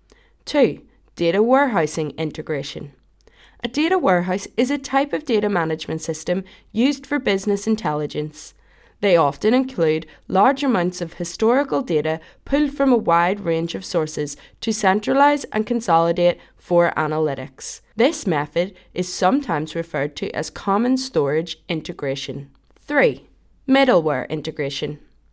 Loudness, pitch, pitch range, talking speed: -21 LUFS, 175 Hz, 155-235 Hz, 125 wpm